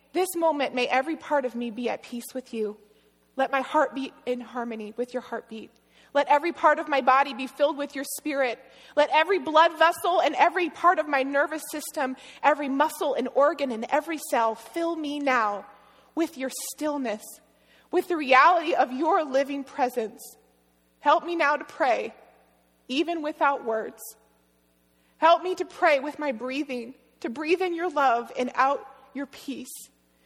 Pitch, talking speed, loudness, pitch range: 275 Hz, 175 wpm, -25 LUFS, 250-310 Hz